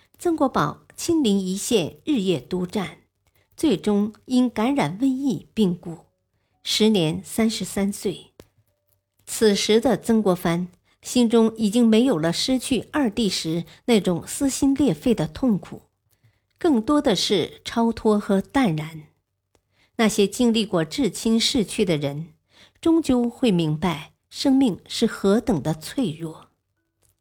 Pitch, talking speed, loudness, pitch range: 205 Hz, 190 characters per minute, -22 LUFS, 160-240 Hz